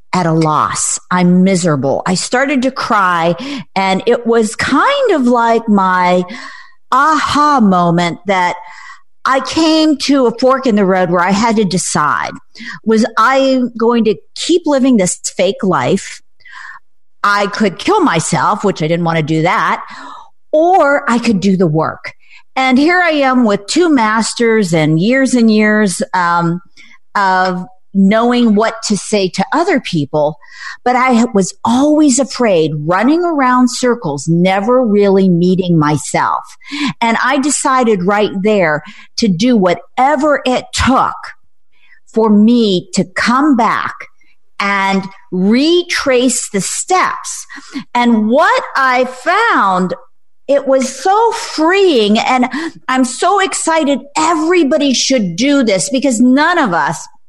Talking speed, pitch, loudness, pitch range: 135 wpm, 235 Hz, -12 LUFS, 190-275 Hz